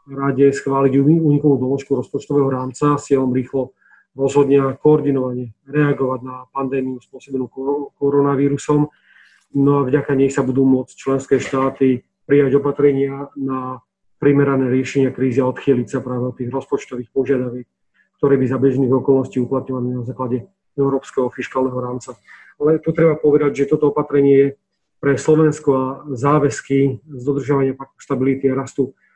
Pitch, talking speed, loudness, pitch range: 135 Hz, 140 wpm, -18 LUFS, 130-140 Hz